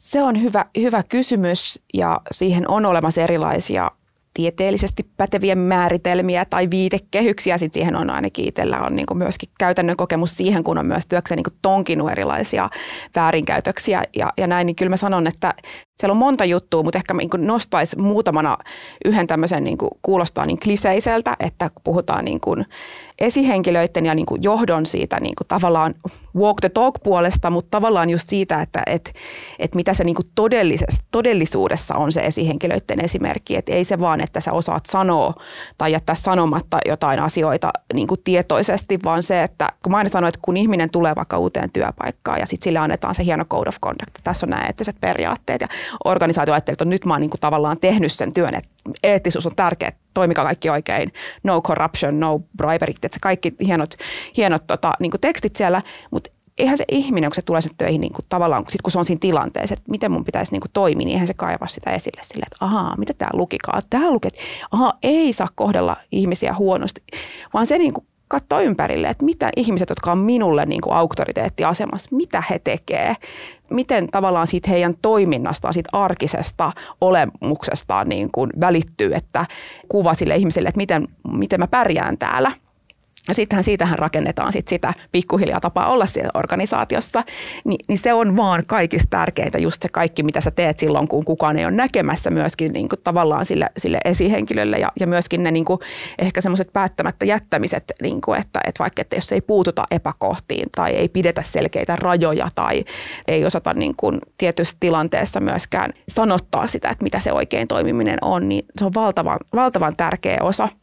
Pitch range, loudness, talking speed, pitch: 165-200 Hz, -19 LUFS, 180 wpm, 180 Hz